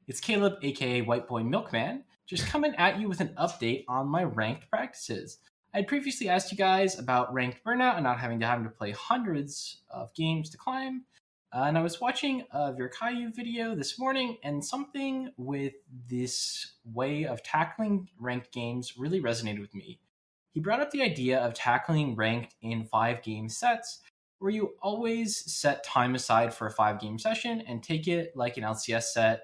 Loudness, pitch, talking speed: -30 LUFS, 145 Hz, 180 wpm